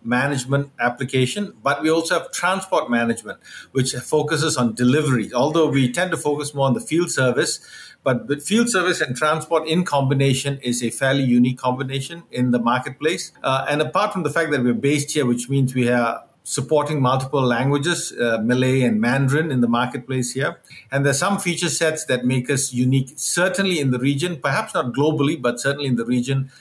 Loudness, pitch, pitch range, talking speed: -20 LUFS, 135 Hz, 125-155 Hz, 190 wpm